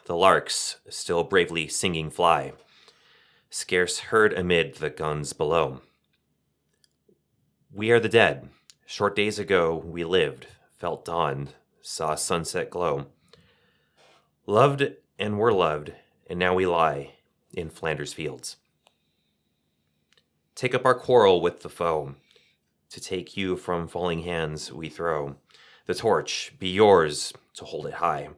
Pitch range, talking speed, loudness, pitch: 75-95 Hz, 125 wpm, -25 LUFS, 85 Hz